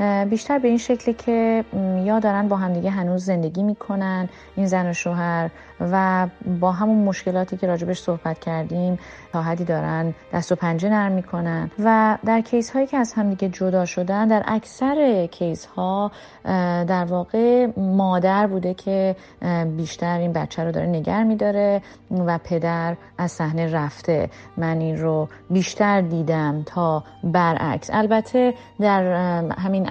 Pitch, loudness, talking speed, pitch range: 185 Hz, -22 LUFS, 145 wpm, 170-205 Hz